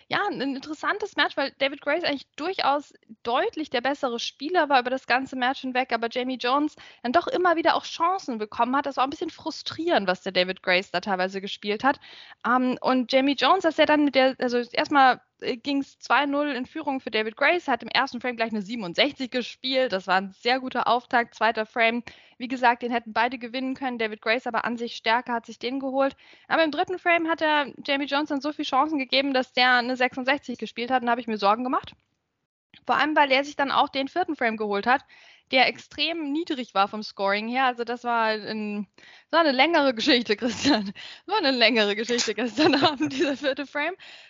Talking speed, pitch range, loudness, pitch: 210 wpm, 235-290 Hz, -24 LUFS, 260 Hz